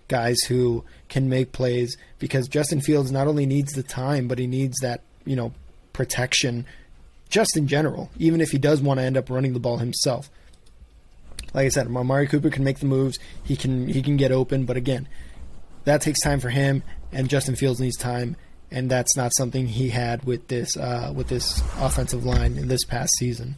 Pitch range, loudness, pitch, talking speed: 125-140 Hz, -23 LUFS, 130 Hz, 200 wpm